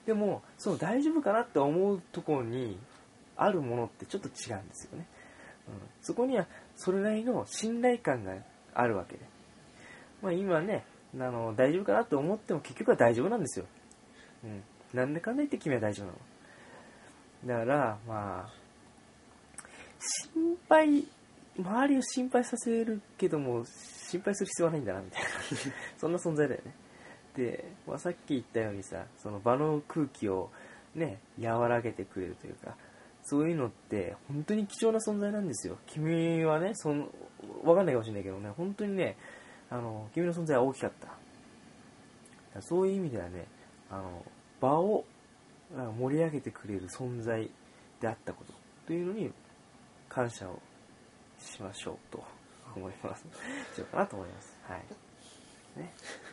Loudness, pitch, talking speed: -33 LUFS, 150 Hz, 305 characters per minute